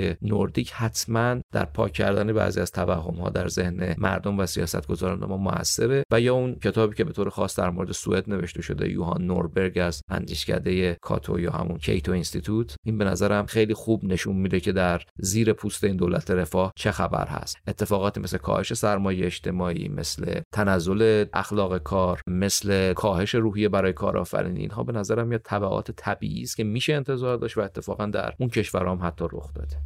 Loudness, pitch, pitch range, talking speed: -25 LUFS, 95 Hz, 90-105 Hz, 180 wpm